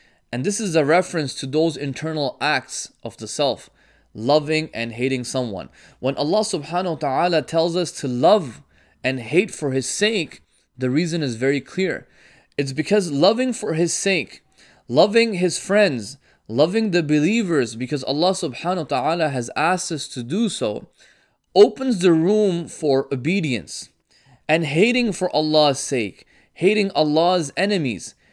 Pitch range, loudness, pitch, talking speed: 135-185 Hz, -20 LUFS, 160 Hz, 150 wpm